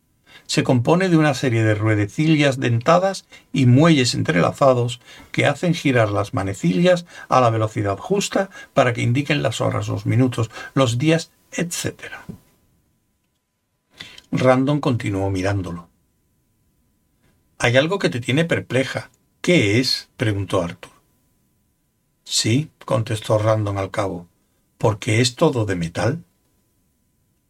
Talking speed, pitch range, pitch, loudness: 115 wpm, 110-150 Hz, 125 Hz, -19 LUFS